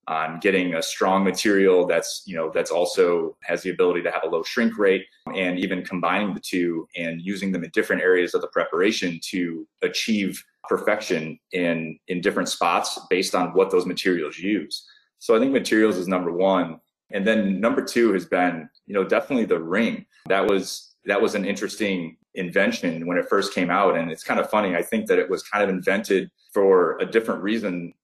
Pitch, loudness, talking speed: 110 Hz, -23 LUFS, 200 wpm